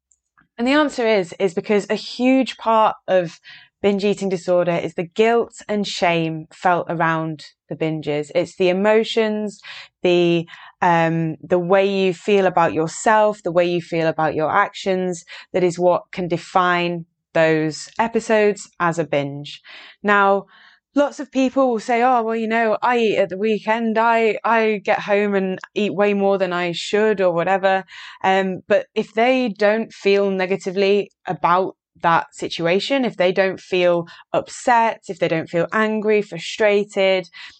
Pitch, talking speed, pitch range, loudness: 195 Hz, 160 wpm, 175-215 Hz, -19 LUFS